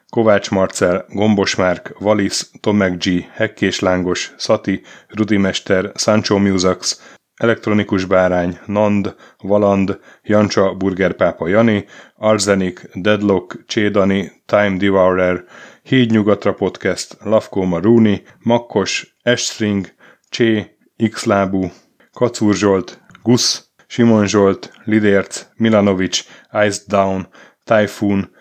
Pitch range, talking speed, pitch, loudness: 95-110 Hz, 90 wpm, 100 Hz, -16 LUFS